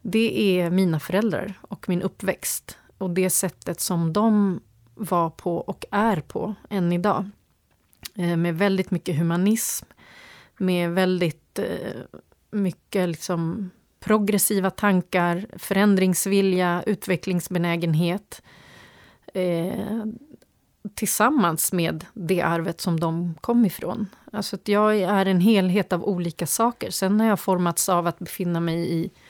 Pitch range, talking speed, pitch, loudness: 175-205 Hz, 115 wpm, 185 Hz, -23 LUFS